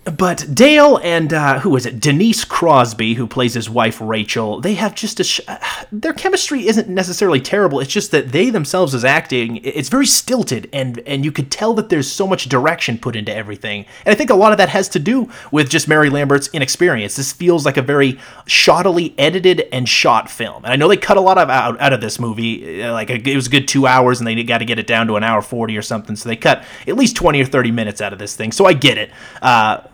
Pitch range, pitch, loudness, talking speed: 115-185 Hz, 140 Hz, -14 LUFS, 245 wpm